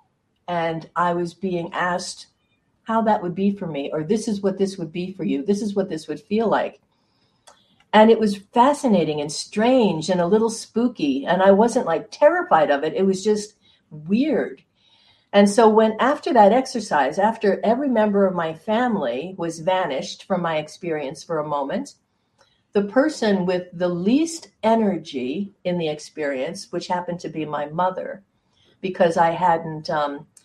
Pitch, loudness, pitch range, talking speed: 190 Hz, -21 LUFS, 170-220 Hz, 170 wpm